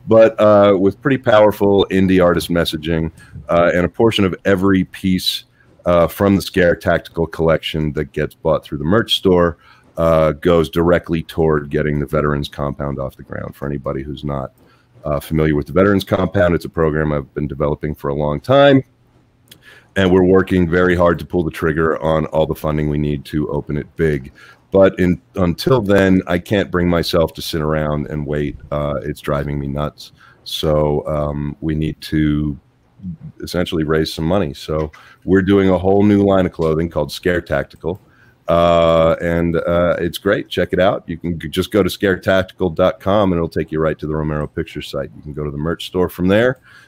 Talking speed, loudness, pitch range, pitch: 190 wpm, -17 LUFS, 75-95 Hz, 85 Hz